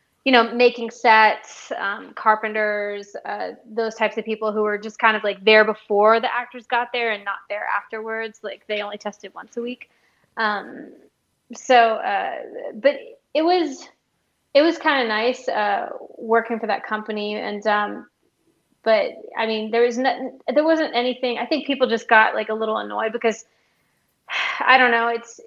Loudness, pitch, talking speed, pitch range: -20 LUFS, 230 Hz, 175 wpm, 215-250 Hz